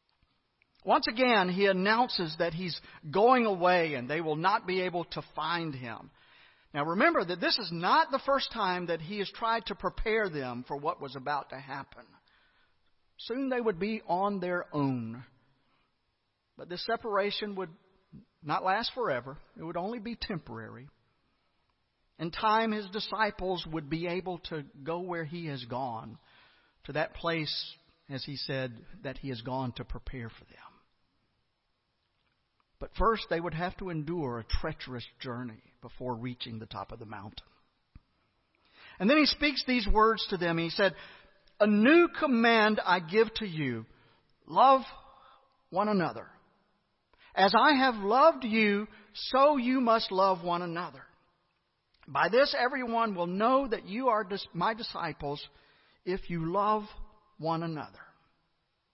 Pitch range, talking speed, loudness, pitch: 145-220 Hz, 150 wpm, -29 LUFS, 180 Hz